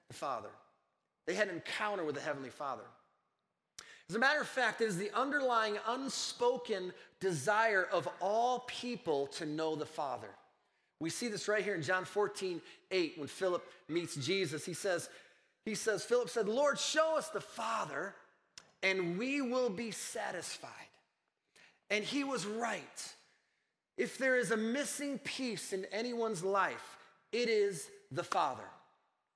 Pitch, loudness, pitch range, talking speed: 215 Hz, -36 LUFS, 185-245 Hz, 150 wpm